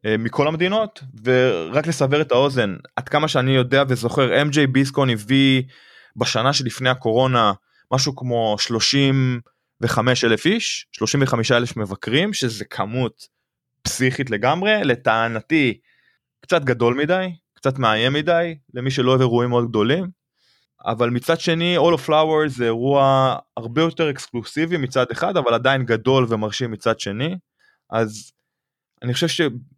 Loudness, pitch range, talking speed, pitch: -19 LUFS, 120-150 Hz, 130 wpm, 130 Hz